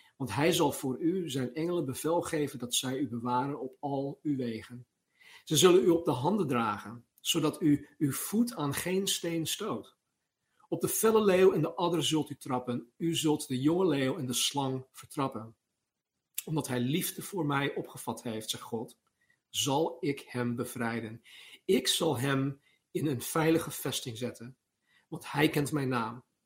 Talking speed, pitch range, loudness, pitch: 175 wpm, 125-165 Hz, -31 LUFS, 140 Hz